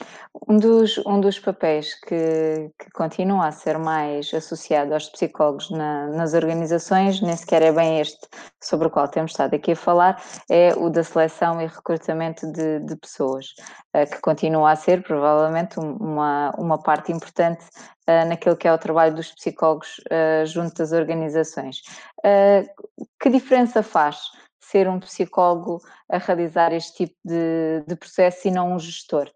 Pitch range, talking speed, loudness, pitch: 155-180 Hz, 155 wpm, -21 LUFS, 165 Hz